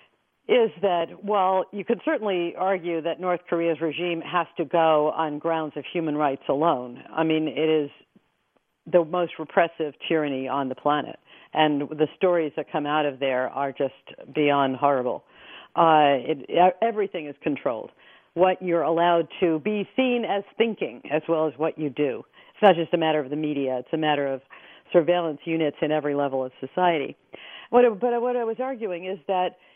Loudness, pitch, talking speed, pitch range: -24 LUFS, 165 Hz, 180 wpm, 150-180 Hz